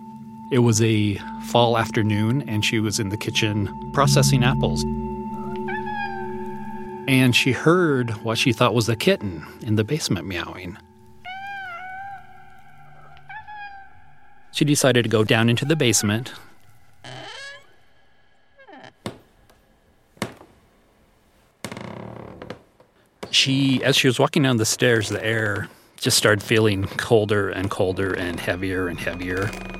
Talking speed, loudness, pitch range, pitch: 110 wpm, -21 LUFS, 95-130 Hz, 110 Hz